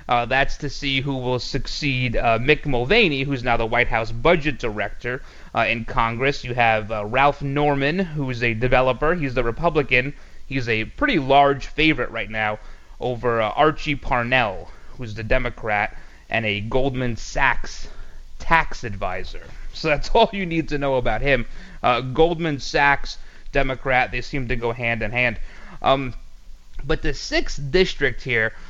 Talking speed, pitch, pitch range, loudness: 165 wpm, 130 Hz, 115-145 Hz, -21 LUFS